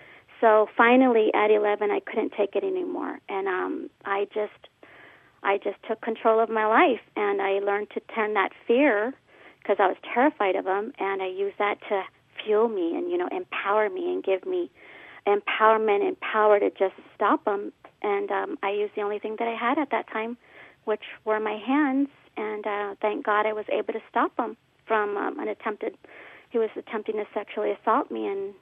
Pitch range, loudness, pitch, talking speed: 205-295 Hz, -25 LUFS, 220 Hz, 195 wpm